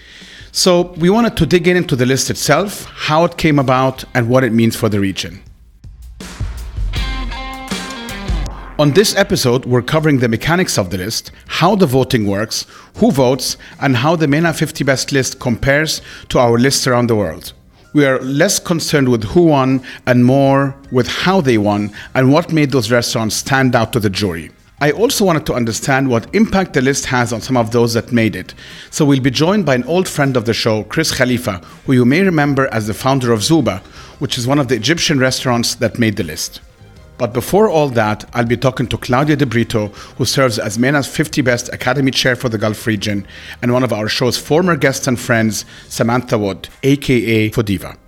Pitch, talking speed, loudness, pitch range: 125 Hz, 200 wpm, -15 LUFS, 115-145 Hz